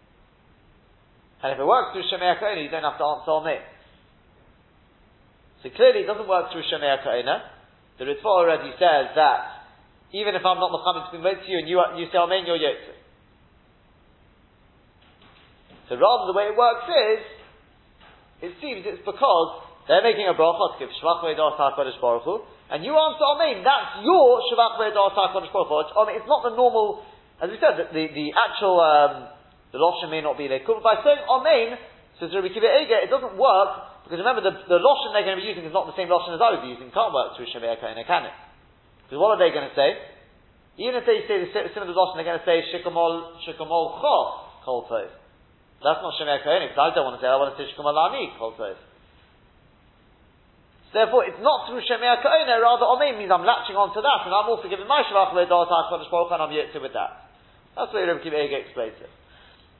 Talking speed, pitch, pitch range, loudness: 205 wpm, 185 Hz, 160-245 Hz, -22 LUFS